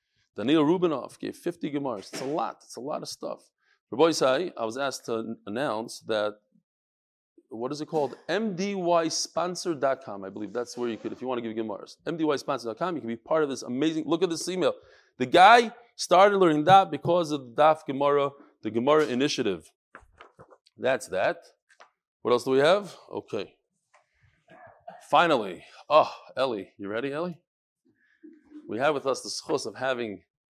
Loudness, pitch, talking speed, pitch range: -26 LUFS, 150 Hz, 165 wpm, 125-180 Hz